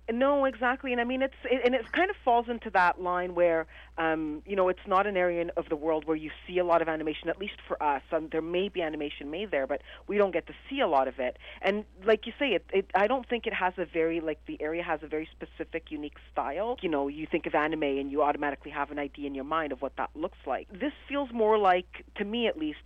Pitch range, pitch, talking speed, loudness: 155-220 Hz, 175 Hz, 275 wpm, -29 LUFS